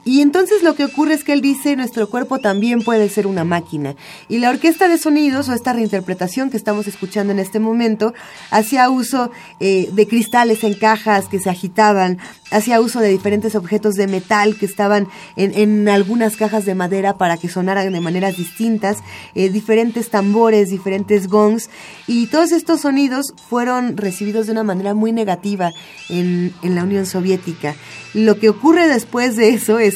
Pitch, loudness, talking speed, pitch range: 215 Hz, -16 LUFS, 180 wpm, 195-235 Hz